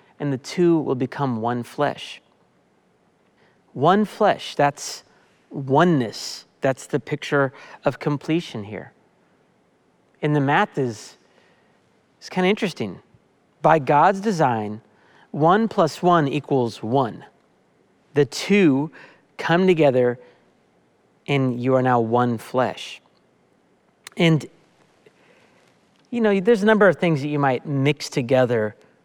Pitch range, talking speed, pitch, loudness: 125-170 Hz, 115 wpm, 145 Hz, -21 LUFS